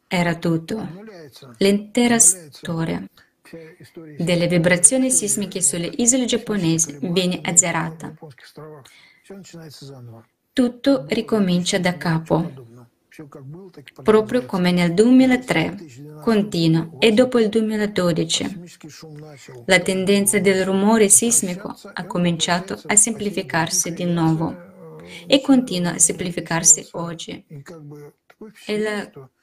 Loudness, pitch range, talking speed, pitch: -18 LUFS, 160-210 Hz, 90 wpm, 175 Hz